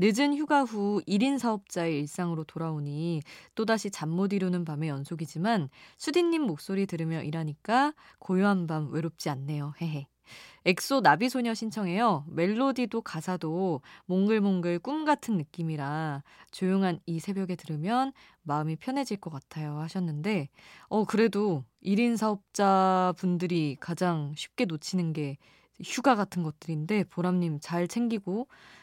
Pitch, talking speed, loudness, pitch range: 180 Hz, 300 characters per minute, -29 LUFS, 160-215 Hz